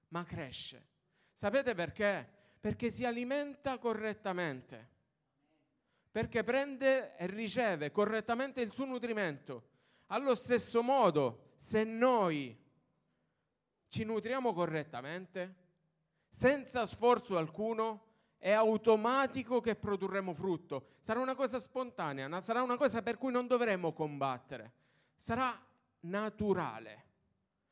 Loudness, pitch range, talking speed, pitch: -35 LUFS, 165-245 Hz, 100 wpm, 215 Hz